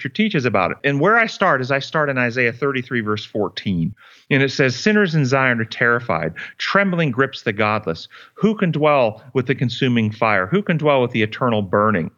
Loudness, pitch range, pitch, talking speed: -18 LUFS, 110-150 Hz, 130 Hz, 200 wpm